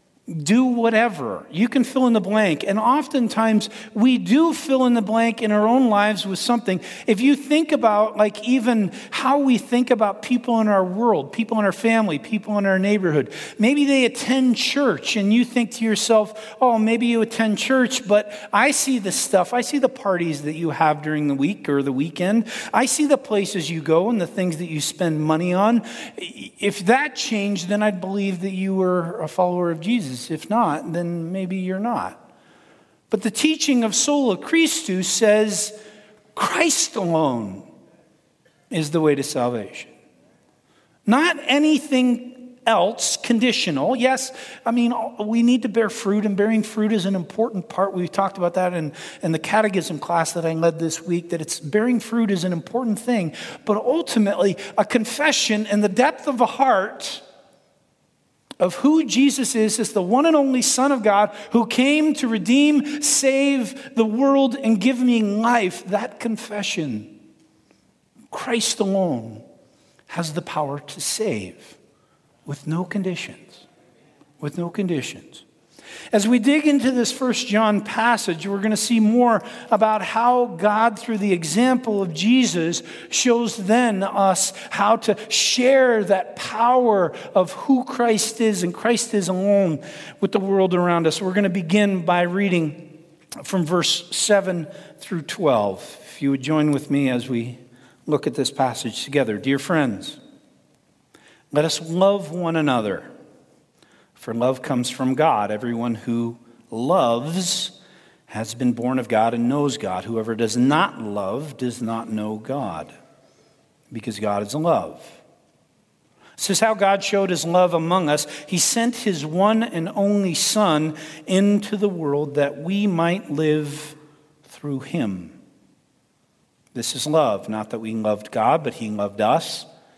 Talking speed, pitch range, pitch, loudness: 160 wpm, 165-235 Hz, 205 Hz, -20 LUFS